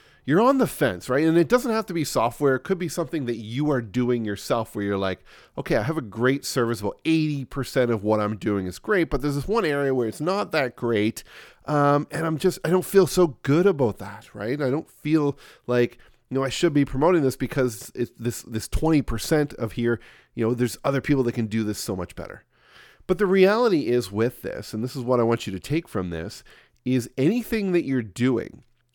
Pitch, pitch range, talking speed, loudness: 130 Hz, 115-155 Hz, 230 wpm, -24 LUFS